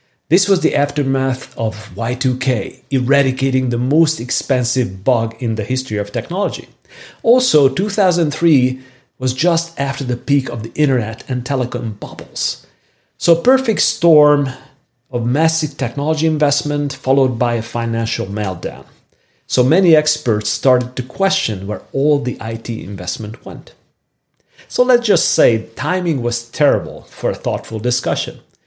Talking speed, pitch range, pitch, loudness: 135 wpm, 120-150 Hz, 130 Hz, -16 LUFS